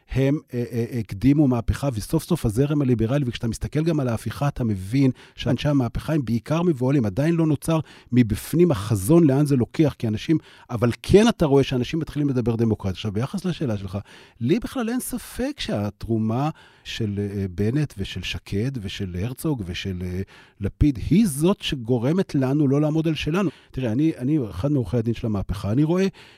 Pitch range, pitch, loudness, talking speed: 110-155 Hz, 130 Hz, -23 LUFS, 175 wpm